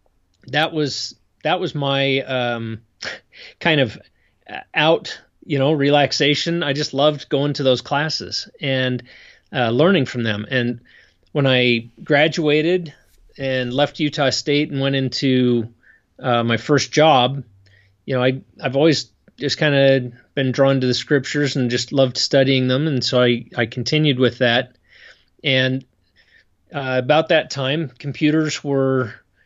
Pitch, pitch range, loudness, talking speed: 135 Hz, 125-145 Hz, -19 LUFS, 145 wpm